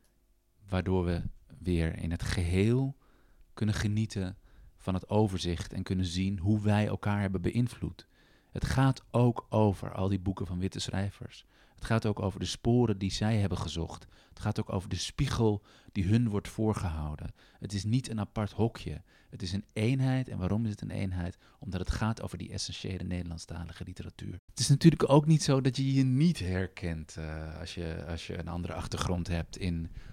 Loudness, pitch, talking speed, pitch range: -31 LUFS, 100 Hz, 185 wpm, 90-110 Hz